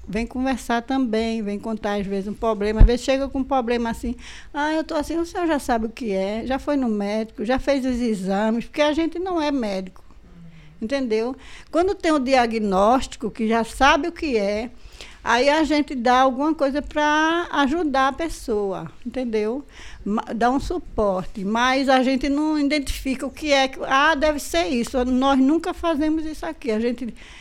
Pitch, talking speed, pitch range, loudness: 260 Hz, 190 wpm, 225-295 Hz, -22 LUFS